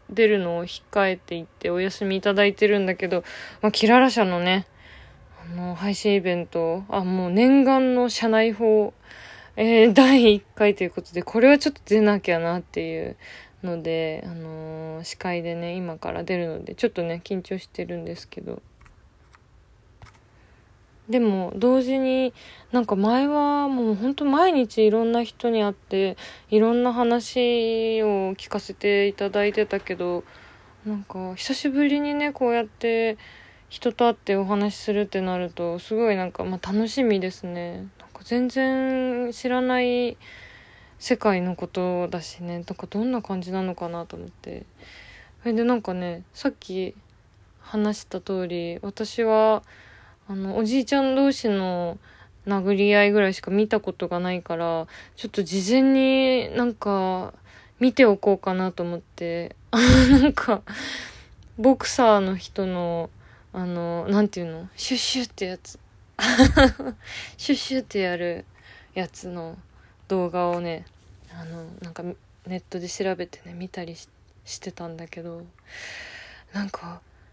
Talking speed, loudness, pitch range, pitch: 280 characters per minute, -23 LUFS, 175-230 Hz, 195 Hz